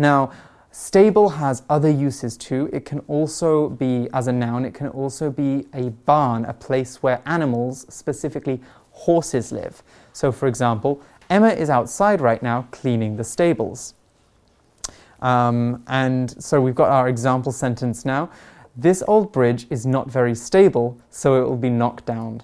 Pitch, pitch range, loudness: 130 Hz, 120-150 Hz, -20 LUFS